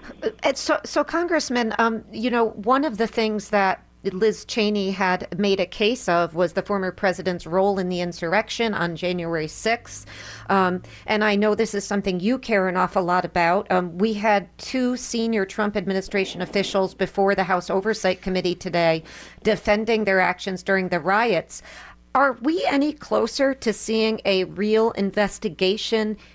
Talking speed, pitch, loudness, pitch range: 160 wpm, 200 Hz, -22 LUFS, 185-225 Hz